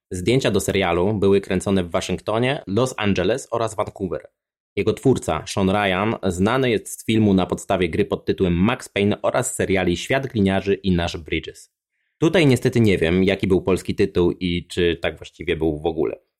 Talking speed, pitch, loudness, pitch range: 180 wpm, 95 Hz, -21 LUFS, 90-105 Hz